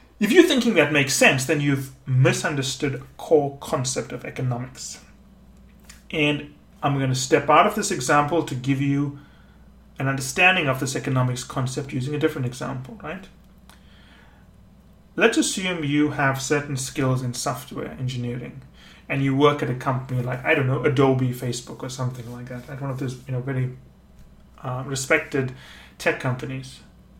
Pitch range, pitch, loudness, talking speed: 130-150 Hz, 135 Hz, -22 LUFS, 160 wpm